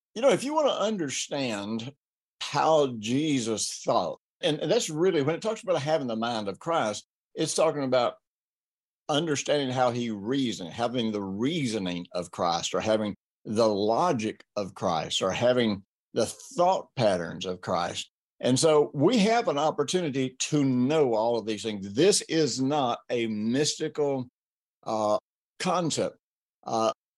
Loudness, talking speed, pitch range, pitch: -27 LUFS, 150 wpm, 105-150 Hz, 125 Hz